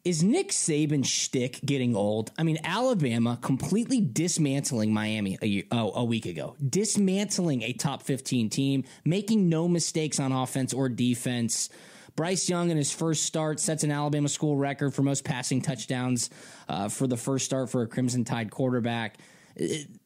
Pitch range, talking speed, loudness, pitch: 125-160 Hz, 170 wpm, -27 LUFS, 140 Hz